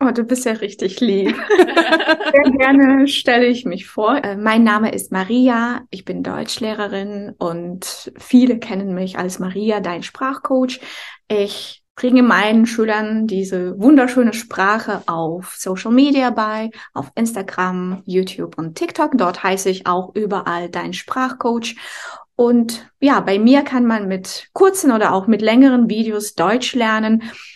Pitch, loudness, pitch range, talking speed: 220 Hz, -16 LUFS, 190-255 Hz, 145 wpm